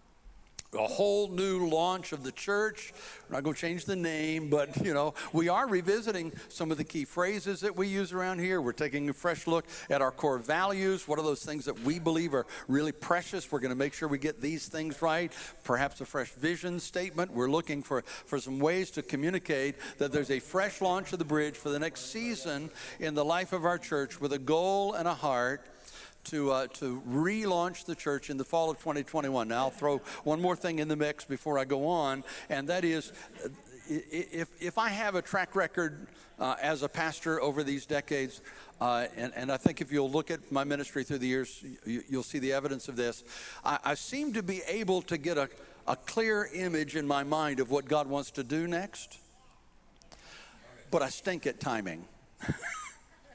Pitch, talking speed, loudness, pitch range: 155 Hz, 210 wpm, -32 LUFS, 140-180 Hz